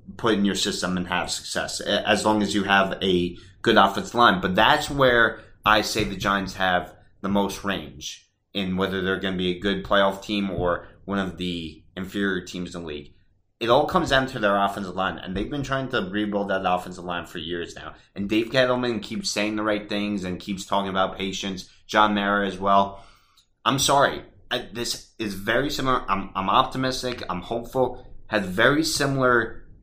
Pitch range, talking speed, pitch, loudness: 95-110 Hz, 195 wpm, 100 Hz, -23 LUFS